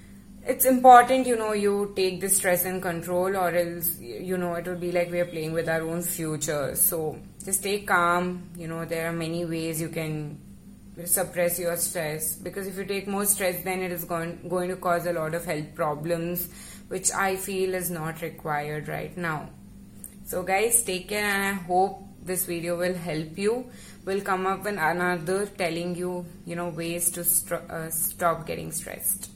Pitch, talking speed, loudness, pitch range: 175 Hz, 190 wpm, -26 LUFS, 170-190 Hz